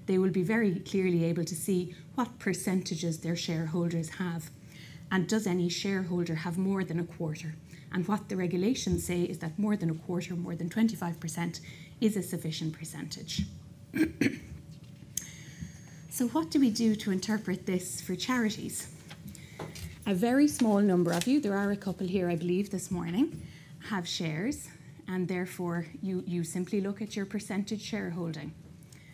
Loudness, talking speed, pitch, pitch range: -32 LUFS, 160 wpm, 180 Hz, 170-200 Hz